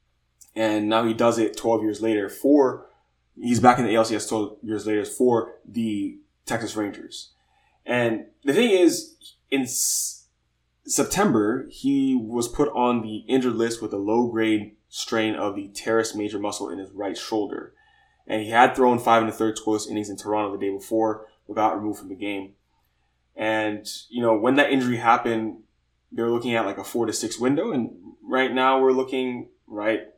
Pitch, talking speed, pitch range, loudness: 110 Hz, 180 wpm, 105-120 Hz, -23 LUFS